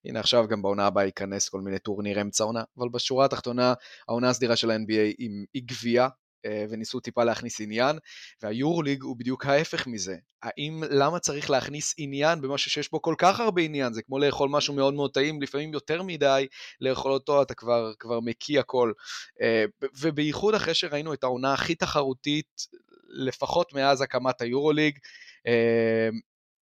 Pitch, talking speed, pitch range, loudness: 135 Hz, 165 wpm, 115-145 Hz, -26 LUFS